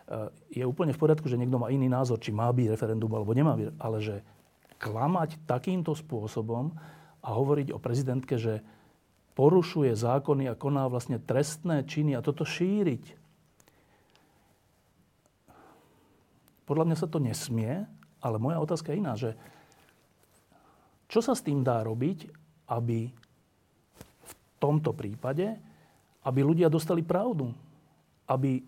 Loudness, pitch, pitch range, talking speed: -30 LUFS, 135 Hz, 120-160 Hz, 130 wpm